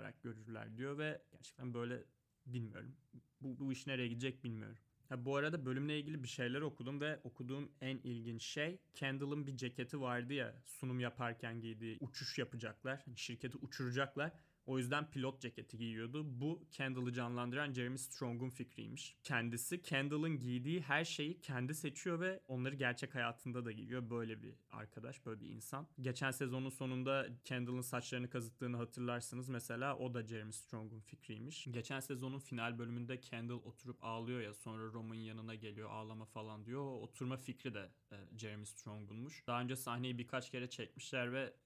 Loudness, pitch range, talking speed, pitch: -44 LUFS, 120-135 Hz, 155 wpm, 125 Hz